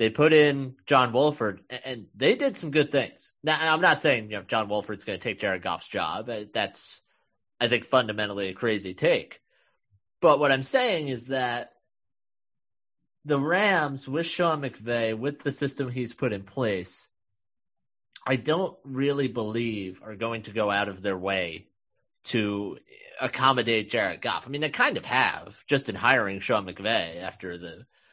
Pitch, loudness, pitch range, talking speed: 125 Hz, -26 LUFS, 105-140 Hz, 170 wpm